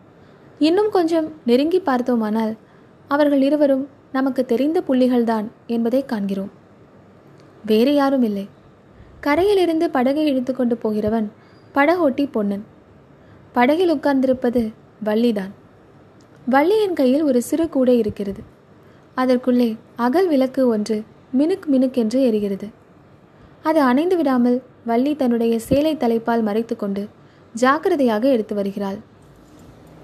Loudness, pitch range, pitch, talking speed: -19 LUFS, 225-285 Hz, 255 Hz, 95 wpm